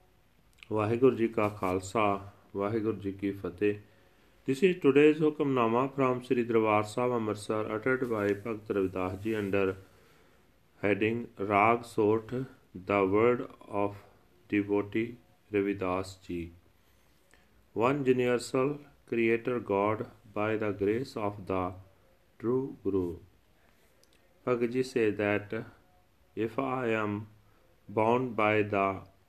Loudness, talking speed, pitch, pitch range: -30 LUFS, 110 wpm, 105 Hz, 95-120 Hz